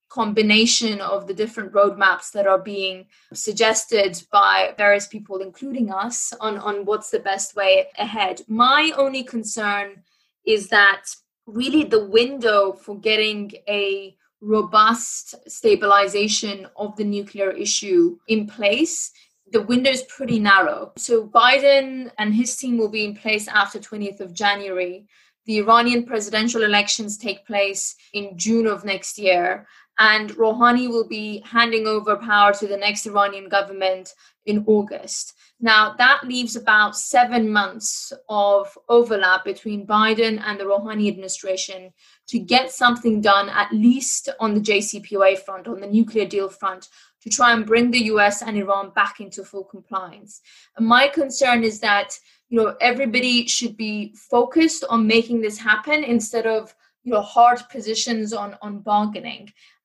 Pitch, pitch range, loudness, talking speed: 215 Hz, 200-235 Hz, -19 LUFS, 150 wpm